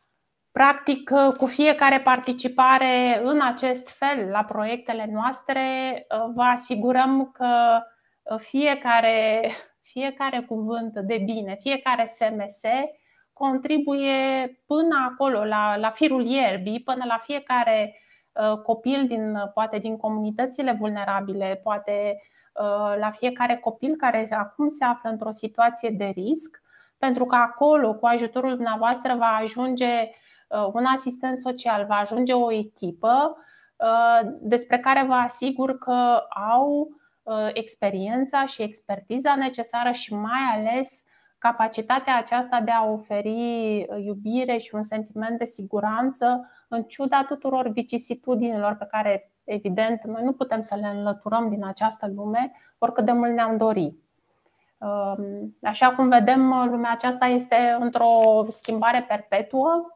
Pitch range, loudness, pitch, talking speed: 220-260 Hz, -23 LUFS, 235 Hz, 115 wpm